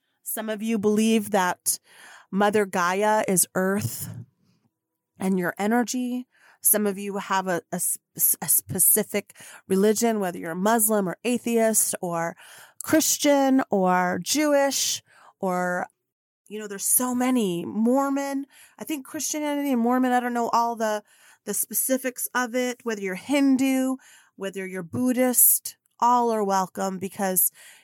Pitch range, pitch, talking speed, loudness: 190-250 Hz, 215 Hz, 135 wpm, -23 LUFS